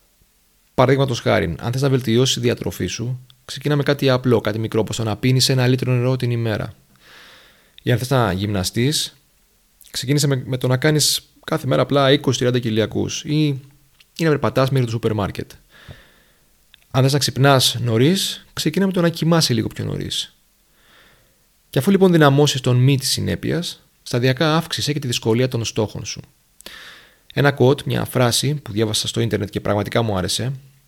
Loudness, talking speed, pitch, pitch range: -19 LUFS, 170 wpm, 130 Hz, 115-140 Hz